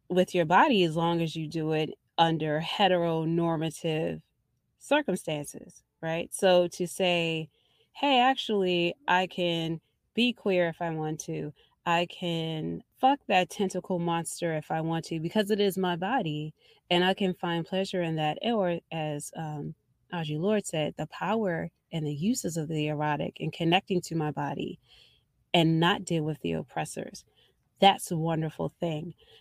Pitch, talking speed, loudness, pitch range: 170 Hz, 155 wpm, -28 LUFS, 160-185 Hz